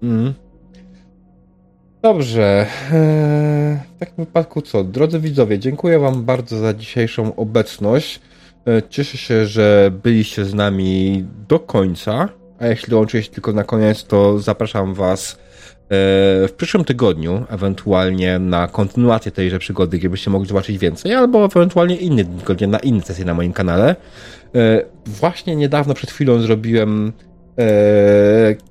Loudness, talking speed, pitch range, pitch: -16 LUFS, 130 wpm, 95-130 Hz, 105 Hz